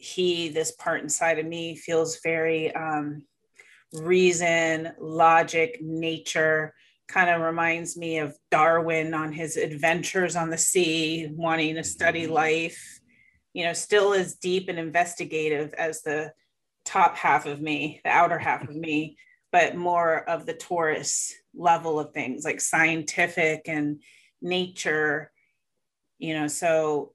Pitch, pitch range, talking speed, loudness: 165 Hz, 155-170 Hz, 135 wpm, -25 LUFS